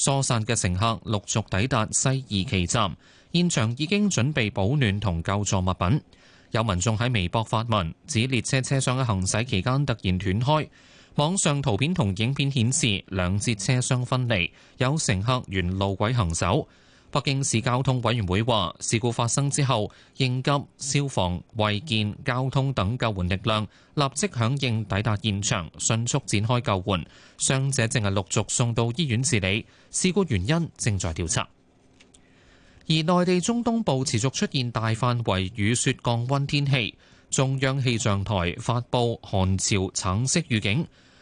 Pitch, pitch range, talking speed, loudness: 115 Hz, 100-135 Hz, 240 characters per minute, -25 LUFS